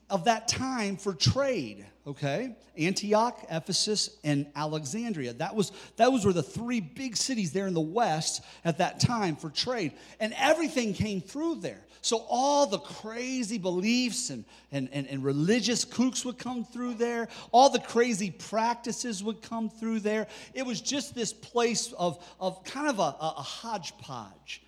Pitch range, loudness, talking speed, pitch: 170-240 Hz, -29 LUFS, 170 wpm, 215 Hz